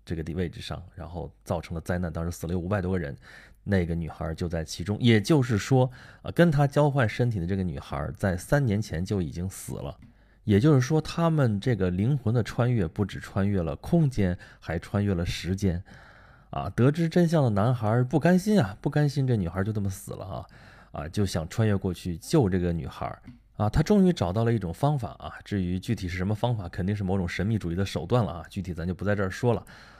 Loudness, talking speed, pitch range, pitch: -27 LUFS, 325 characters per minute, 90-125 Hz, 100 Hz